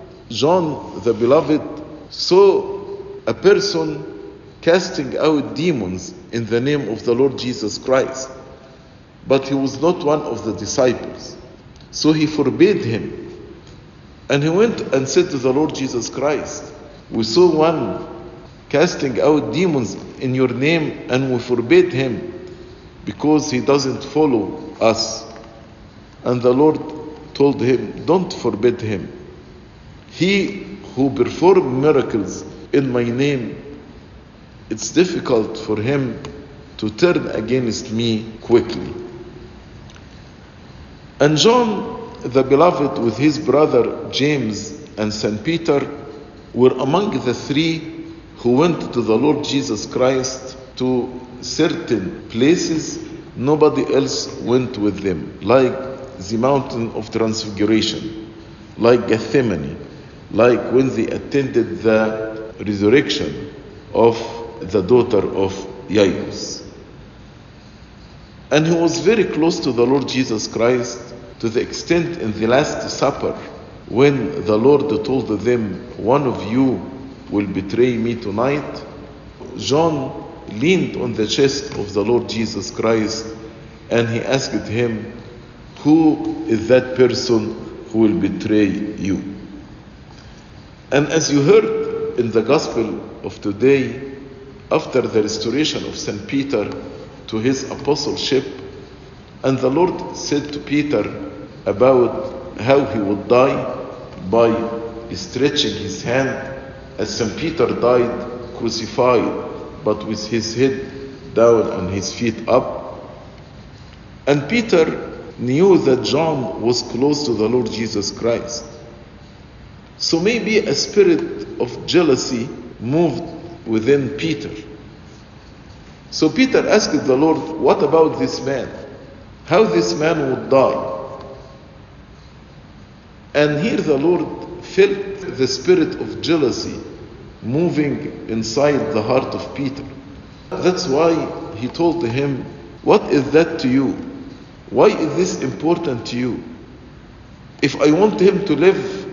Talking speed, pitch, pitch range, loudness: 120 wpm, 130 Hz, 115-150 Hz, -18 LUFS